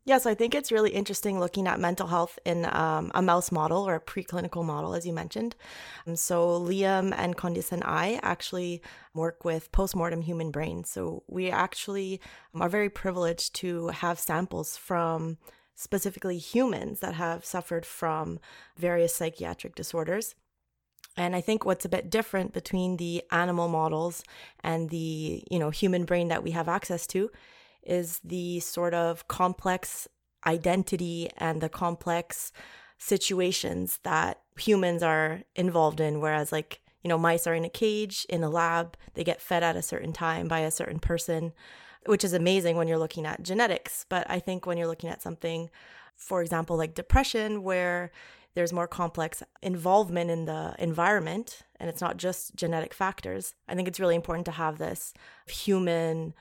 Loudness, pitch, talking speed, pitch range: -29 LUFS, 175 Hz, 165 wpm, 165-185 Hz